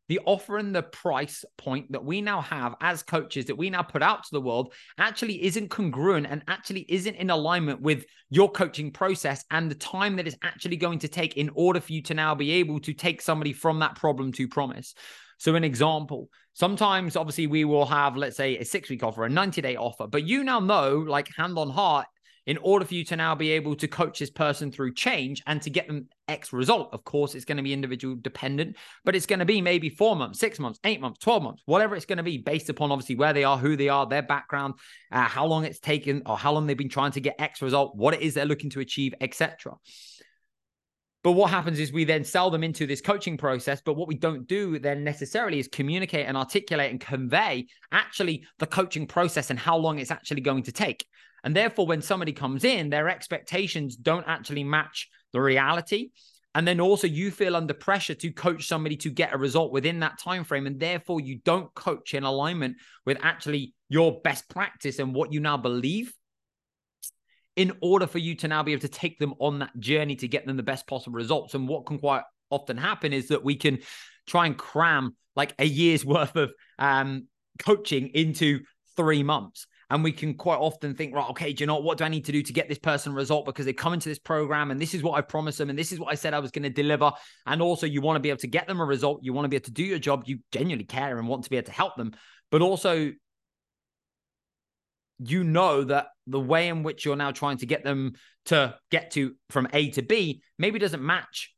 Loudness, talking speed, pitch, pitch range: -26 LUFS, 230 wpm, 150 Hz, 140-170 Hz